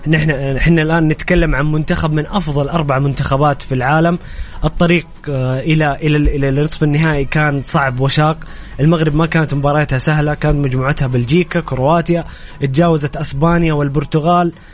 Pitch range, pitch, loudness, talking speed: 140-165 Hz, 150 Hz, -15 LUFS, 125 wpm